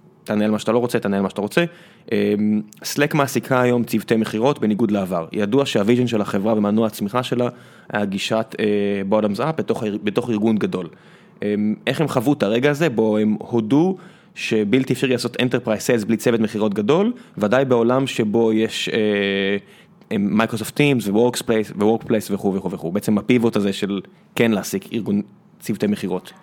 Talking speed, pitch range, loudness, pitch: 155 wpm, 105-125 Hz, -20 LUFS, 110 Hz